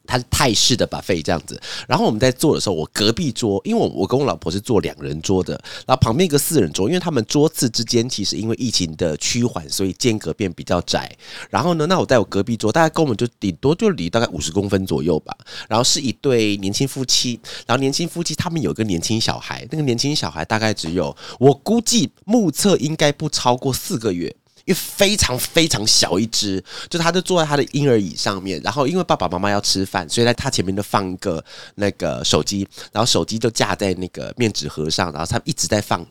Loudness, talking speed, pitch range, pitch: -19 LUFS, 355 characters per minute, 100-145 Hz, 115 Hz